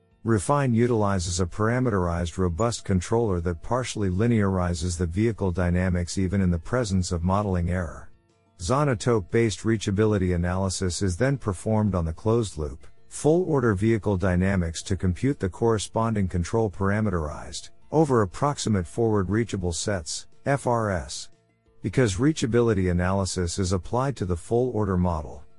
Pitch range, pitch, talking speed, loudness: 90-115 Hz, 100 Hz, 120 wpm, -25 LUFS